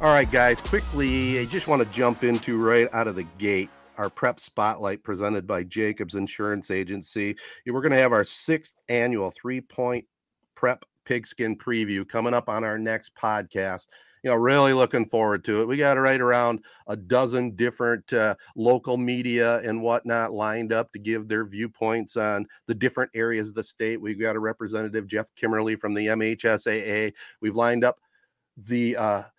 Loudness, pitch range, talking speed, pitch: -25 LUFS, 110-125 Hz, 180 wpm, 115 Hz